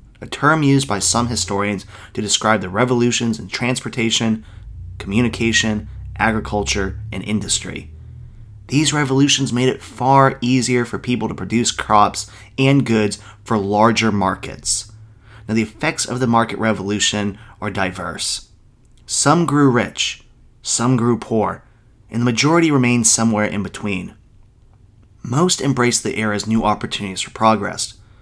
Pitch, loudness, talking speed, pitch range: 110 Hz, -18 LUFS, 130 wpm, 105-120 Hz